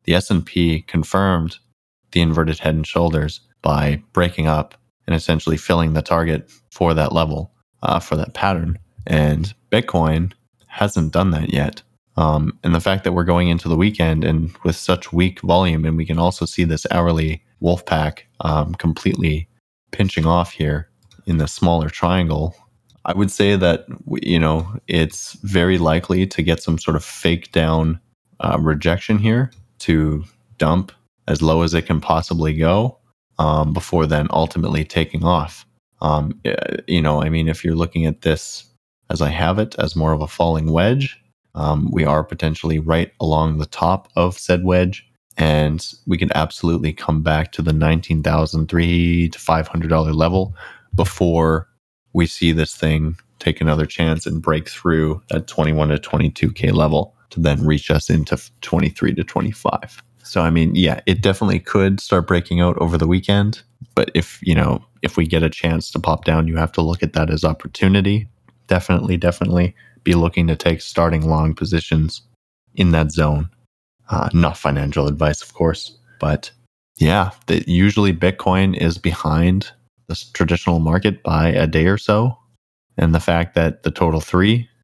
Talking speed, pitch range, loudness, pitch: 165 wpm, 80-90 Hz, -18 LUFS, 85 Hz